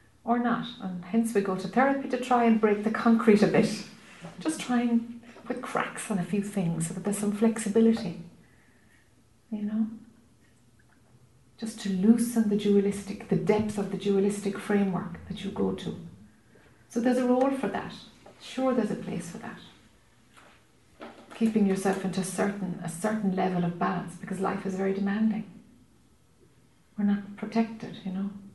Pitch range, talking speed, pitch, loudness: 195-225 Hz, 165 wpm, 205 Hz, -28 LUFS